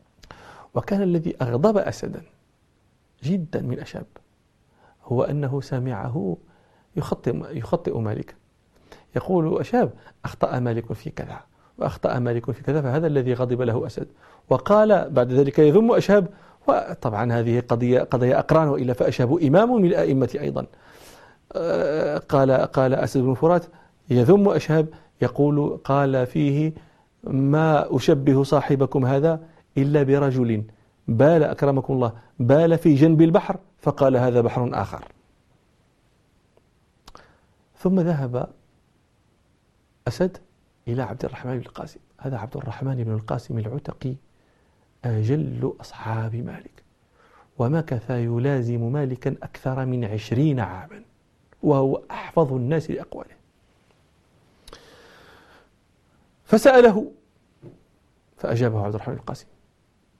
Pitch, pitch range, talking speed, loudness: 135 Hz, 125-160 Hz, 105 wpm, -22 LUFS